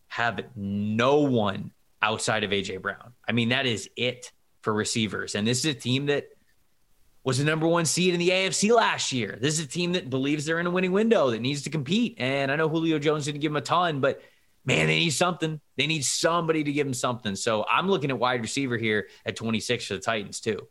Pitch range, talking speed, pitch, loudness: 115-160 Hz, 230 wpm, 135 Hz, -25 LUFS